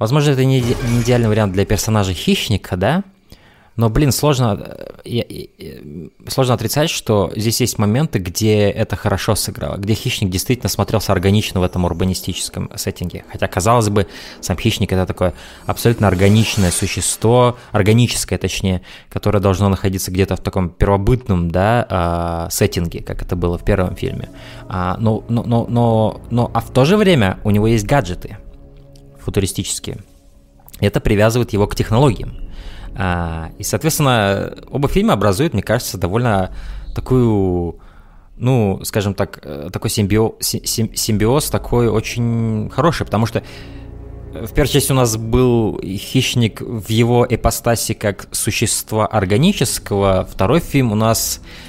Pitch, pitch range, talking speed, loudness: 105 Hz, 95-120 Hz, 135 wpm, -17 LUFS